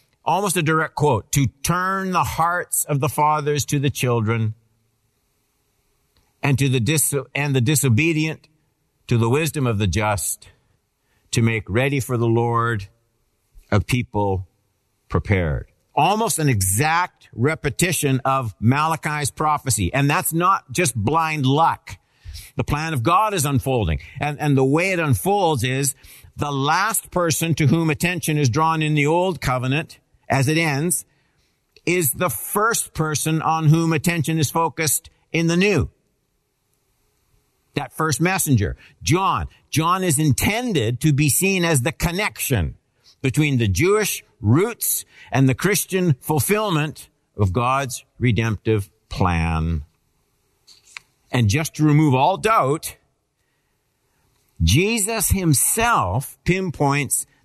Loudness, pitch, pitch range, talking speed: -20 LUFS, 140 Hz, 115-160 Hz, 130 wpm